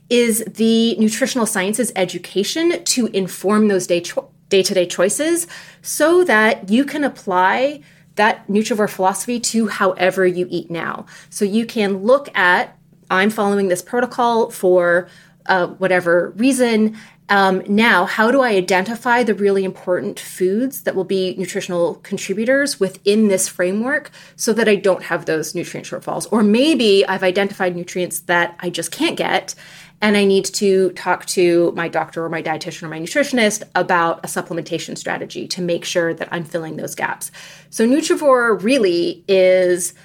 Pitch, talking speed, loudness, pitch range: 190 Hz, 155 wpm, -17 LUFS, 180-225 Hz